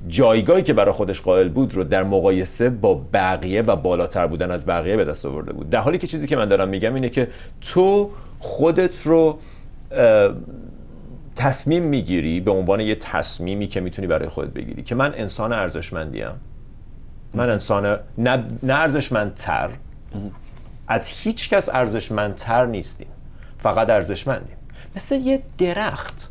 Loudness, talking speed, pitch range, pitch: -20 LUFS, 140 wpm, 95-150 Hz, 115 Hz